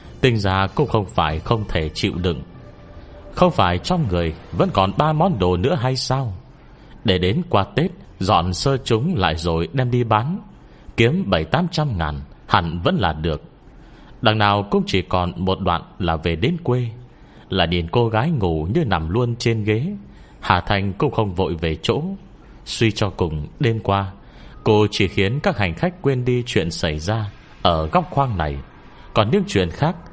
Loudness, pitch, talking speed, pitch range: -20 LUFS, 105 Hz, 185 wpm, 90-130 Hz